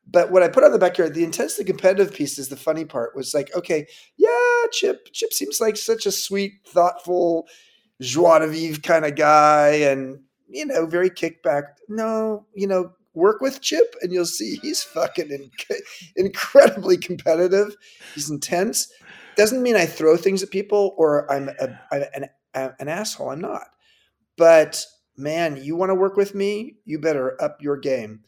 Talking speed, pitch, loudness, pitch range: 180 wpm, 180 Hz, -20 LUFS, 155-210 Hz